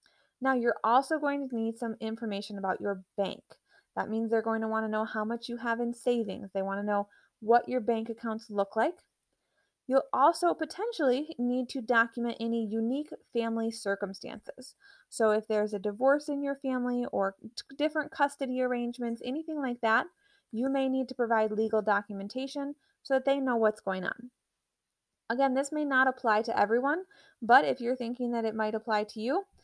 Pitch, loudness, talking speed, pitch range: 240 Hz, -30 LUFS, 185 wpm, 220-270 Hz